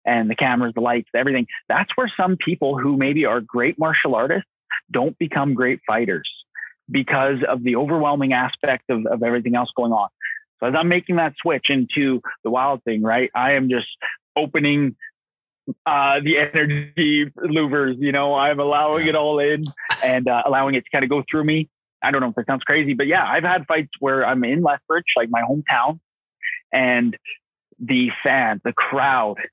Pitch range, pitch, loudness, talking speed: 130-155 Hz, 140 Hz, -20 LUFS, 185 wpm